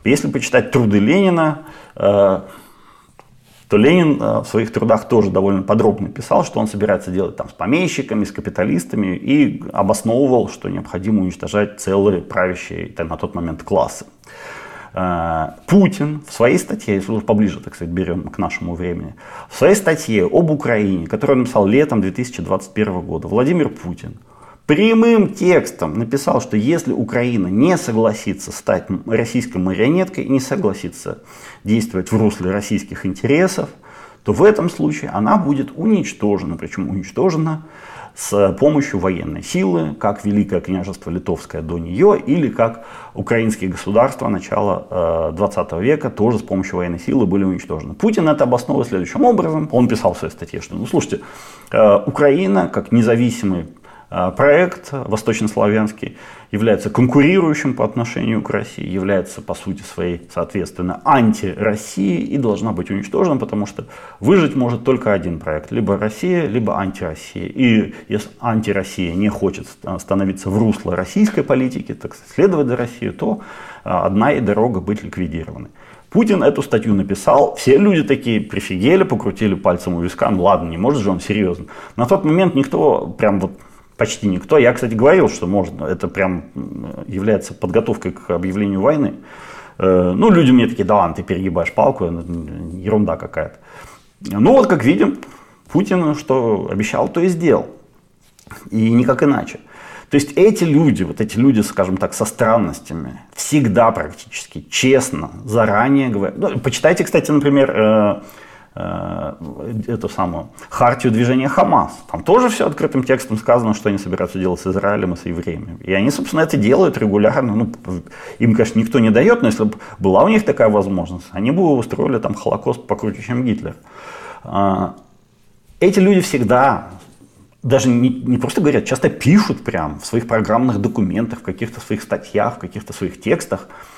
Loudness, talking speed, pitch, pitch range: -17 LUFS, 145 wpm, 110 Hz, 95-135 Hz